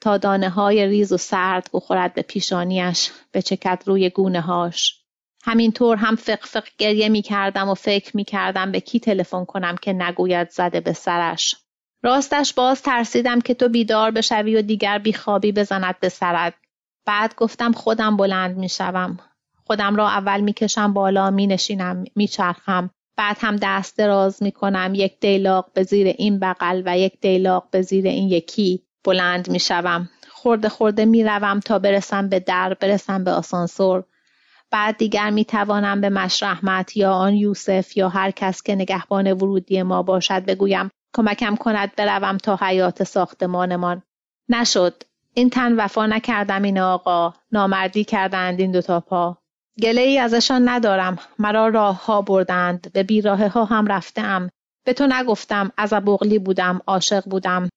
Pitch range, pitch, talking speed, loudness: 185-215 Hz, 195 Hz, 155 wpm, -19 LUFS